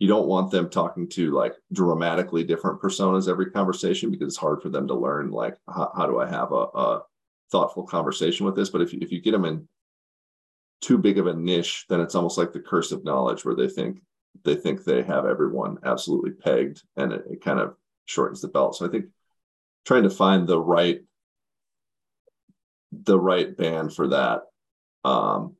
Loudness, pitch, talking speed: -24 LUFS, 95 Hz, 195 wpm